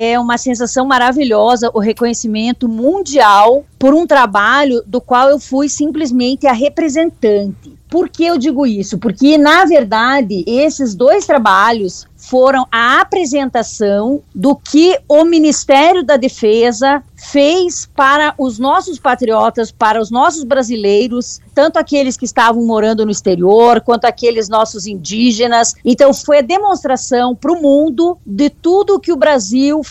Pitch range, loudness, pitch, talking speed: 230-295 Hz, -11 LUFS, 260 Hz, 140 wpm